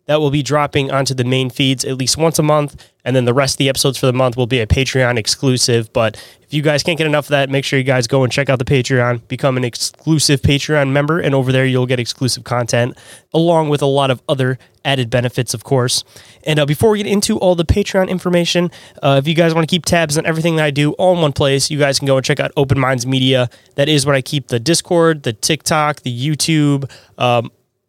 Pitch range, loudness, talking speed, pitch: 130-150 Hz, -15 LUFS, 255 wpm, 140 Hz